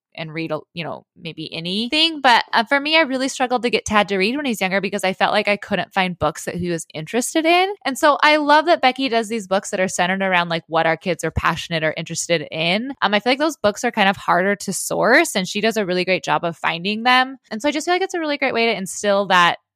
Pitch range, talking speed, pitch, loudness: 175-260 Hz, 280 wpm, 205 Hz, -18 LUFS